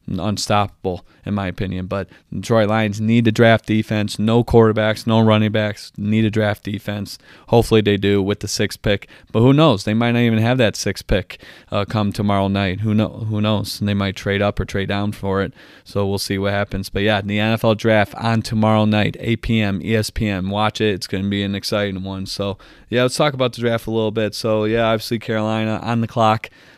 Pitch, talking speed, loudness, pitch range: 105 Hz, 220 wpm, -19 LUFS, 100-110 Hz